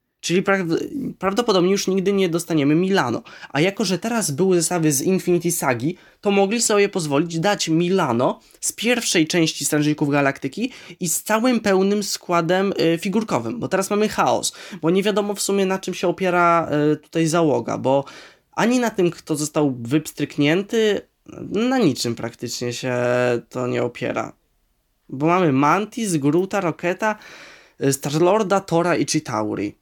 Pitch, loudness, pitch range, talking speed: 175 Hz, -20 LUFS, 150-200 Hz, 145 wpm